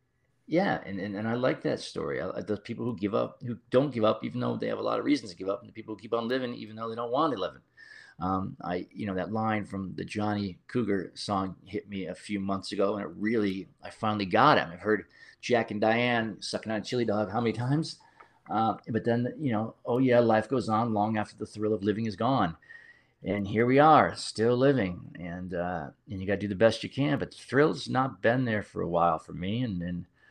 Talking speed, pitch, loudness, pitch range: 255 wpm, 110 Hz, -29 LUFS, 100-120 Hz